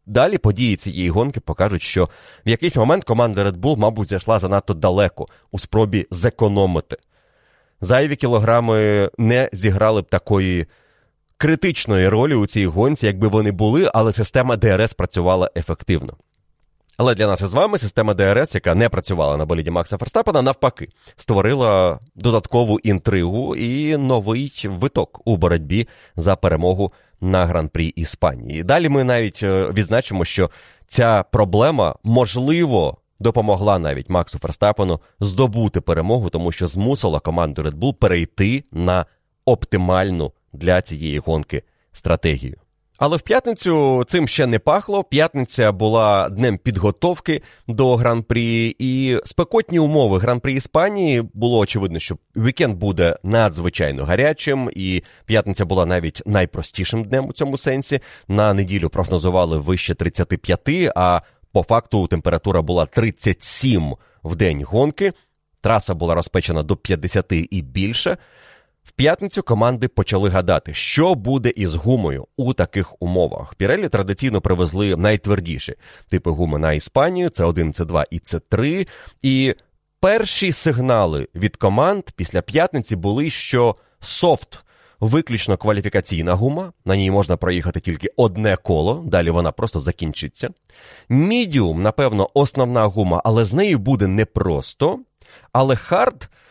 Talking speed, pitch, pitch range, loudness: 130 wpm, 105 Hz, 90-125 Hz, -18 LUFS